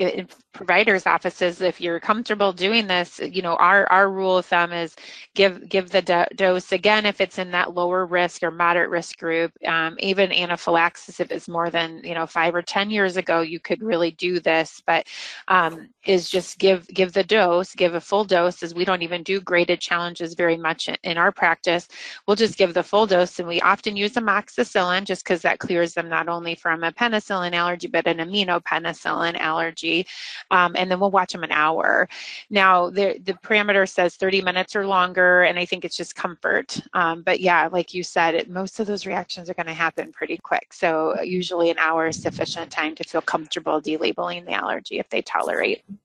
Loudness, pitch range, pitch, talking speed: -21 LUFS, 170-190 Hz, 175 Hz, 205 wpm